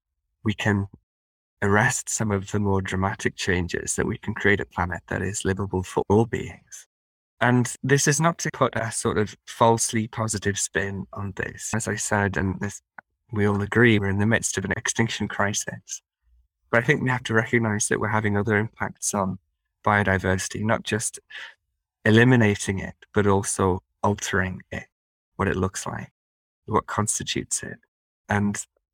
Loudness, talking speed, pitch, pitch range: -24 LUFS, 170 wpm, 100 Hz, 95-110 Hz